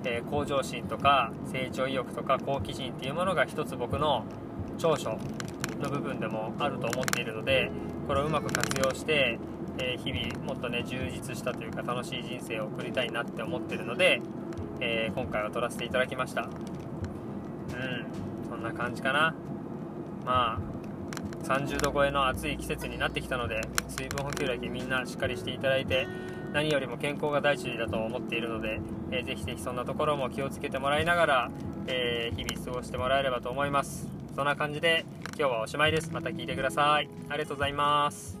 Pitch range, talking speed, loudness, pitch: 120-155 Hz, 385 characters per minute, -30 LUFS, 145 Hz